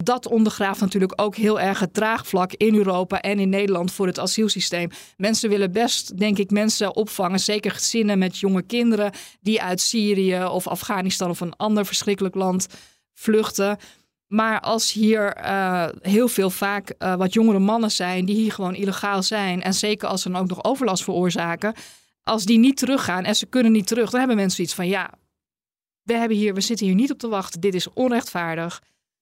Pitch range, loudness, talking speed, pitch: 185-220 Hz, -21 LUFS, 190 wpm, 200 Hz